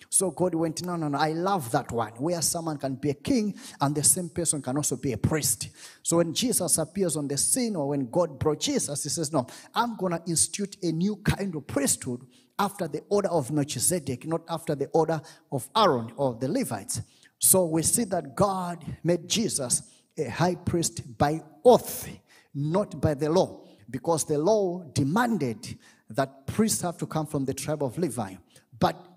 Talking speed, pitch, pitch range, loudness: 190 wpm, 160 Hz, 140-180 Hz, -26 LUFS